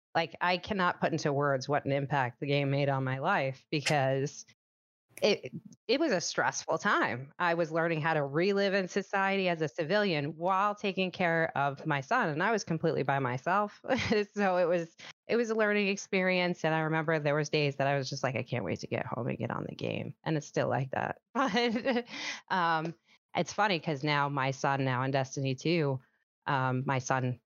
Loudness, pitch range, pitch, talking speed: -31 LUFS, 140-185 Hz, 160 Hz, 210 wpm